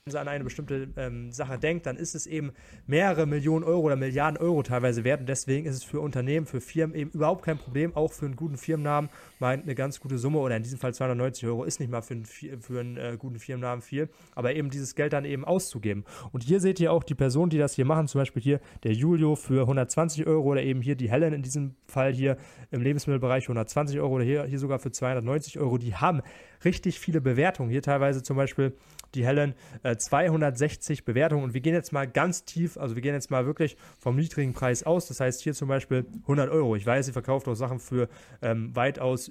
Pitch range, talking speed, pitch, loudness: 130-155 Hz, 230 wpm, 140 Hz, -28 LUFS